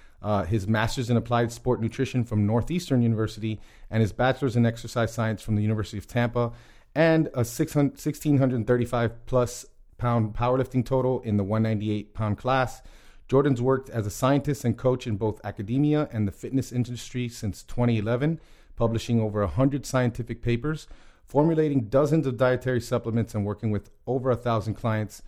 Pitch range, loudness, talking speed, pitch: 110-130 Hz, -26 LUFS, 155 wpm, 120 Hz